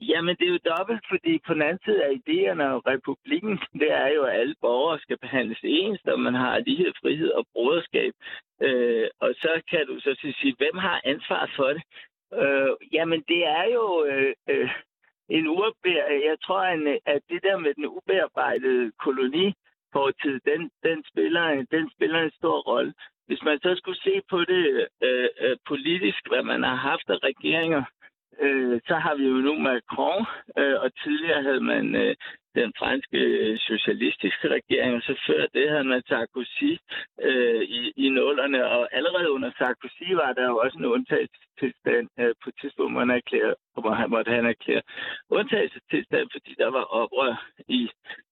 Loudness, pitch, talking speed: -25 LUFS, 255 Hz, 170 wpm